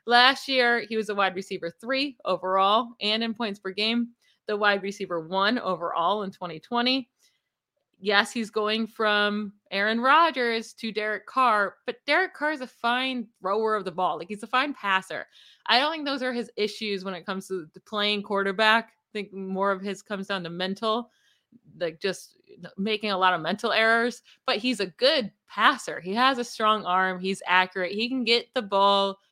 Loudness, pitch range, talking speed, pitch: -25 LUFS, 195-240 Hz, 190 wpm, 210 Hz